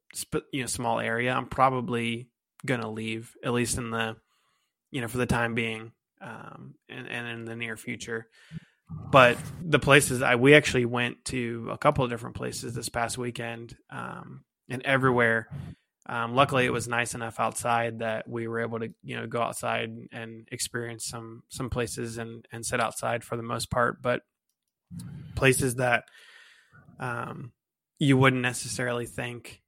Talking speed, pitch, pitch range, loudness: 165 wpm, 120 Hz, 115-130 Hz, -27 LUFS